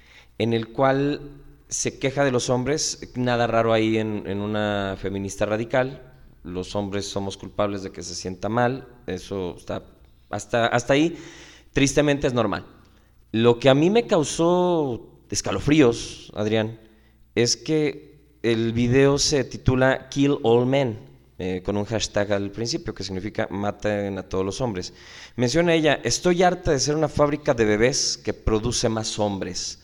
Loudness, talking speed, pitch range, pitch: -23 LUFS, 155 wpm, 100-140 Hz, 115 Hz